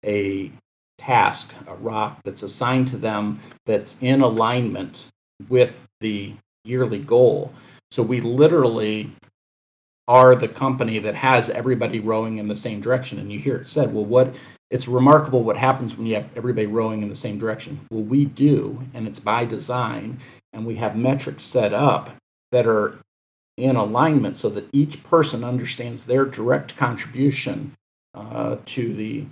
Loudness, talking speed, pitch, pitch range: -21 LUFS, 160 wpm, 120 Hz, 110-130 Hz